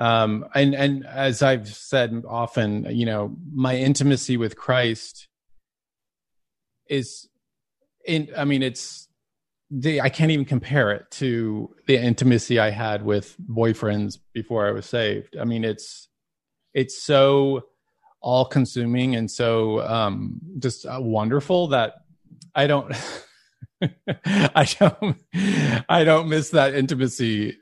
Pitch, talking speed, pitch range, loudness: 130 Hz, 125 wpm, 115-145 Hz, -22 LUFS